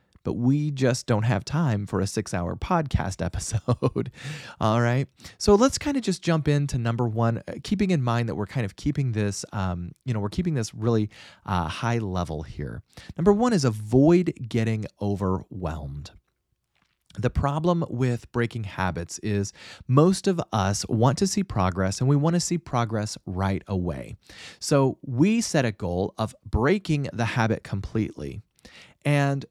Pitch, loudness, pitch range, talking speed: 115 Hz, -25 LUFS, 100-145 Hz, 165 wpm